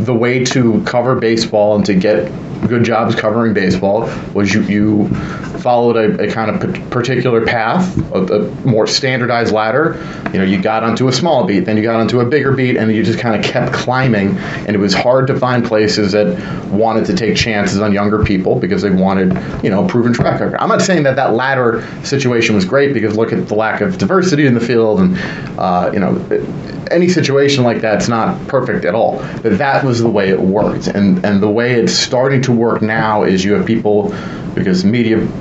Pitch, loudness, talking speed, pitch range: 115 Hz, -13 LUFS, 215 wpm, 105-125 Hz